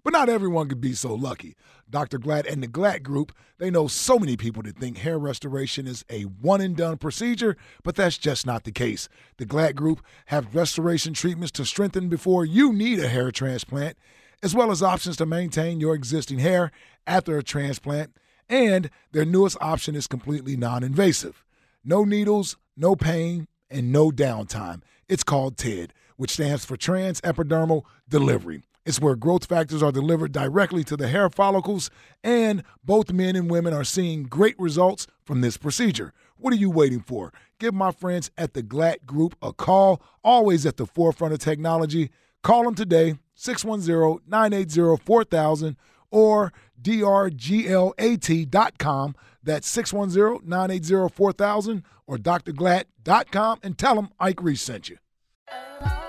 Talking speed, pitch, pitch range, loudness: 155 wpm, 165 Hz, 140-190 Hz, -23 LUFS